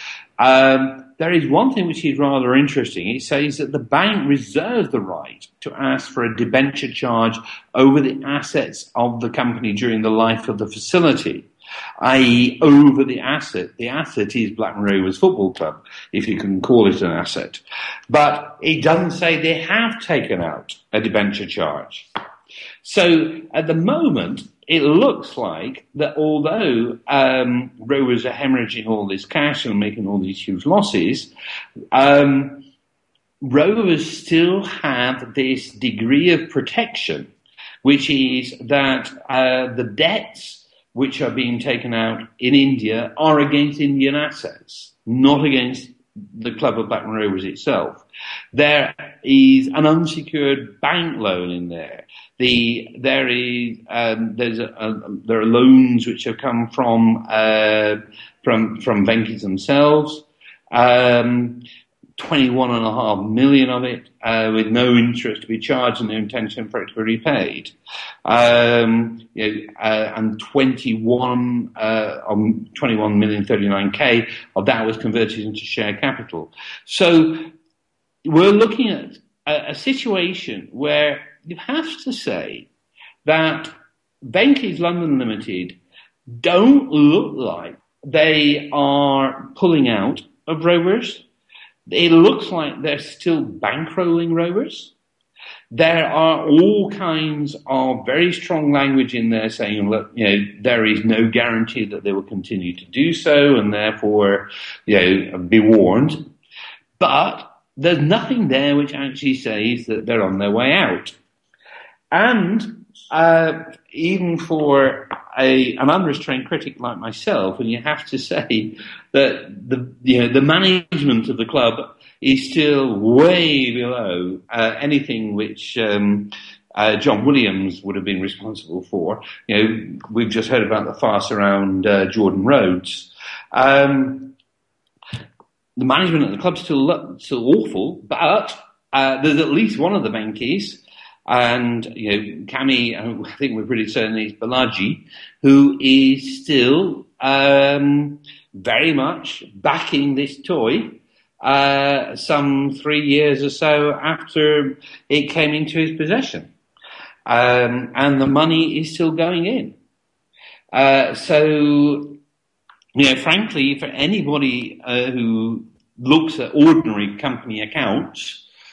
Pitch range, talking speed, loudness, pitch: 115-155 Hz, 140 wpm, -17 LUFS, 135 Hz